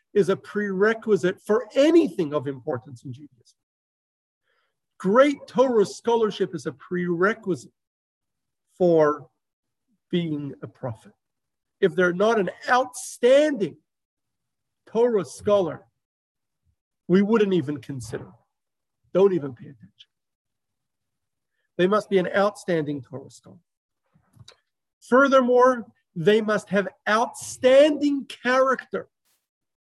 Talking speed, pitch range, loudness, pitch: 95 wpm, 155-235 Hz, -22 LUFS, 195 Hz